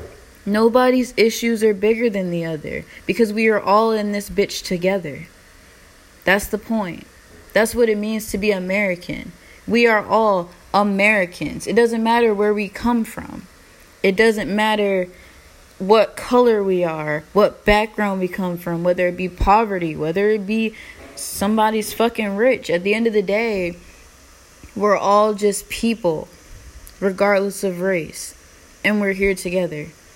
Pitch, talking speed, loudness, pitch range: 200 Hz, 150 wpm, -19 LUFS, 180-215 Hz